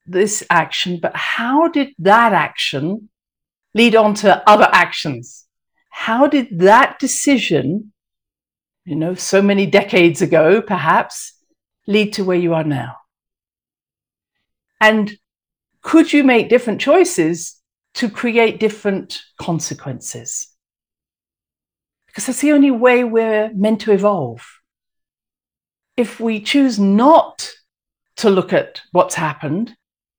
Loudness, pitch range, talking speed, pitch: -15 LUFS, 165-240 Hz, 115 wpm, 205 Hz